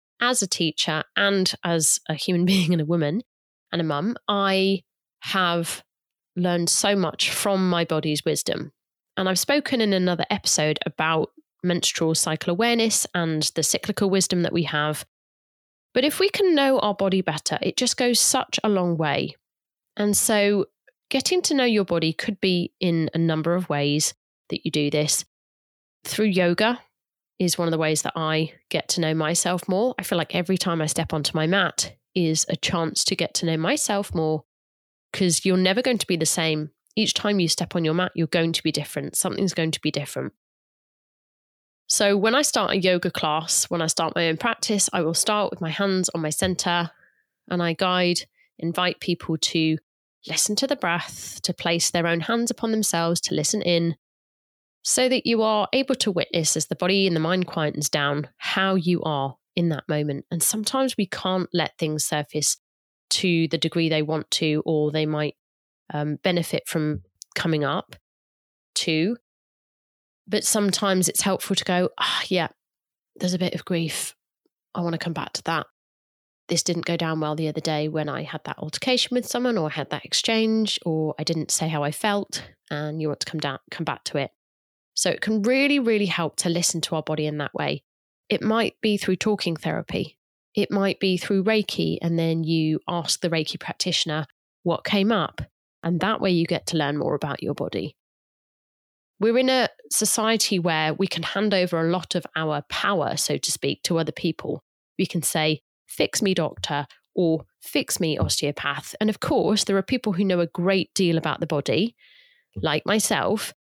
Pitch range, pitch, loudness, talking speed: 155-200 Hz, 175 Hz, -23 LUFS, 195 wpm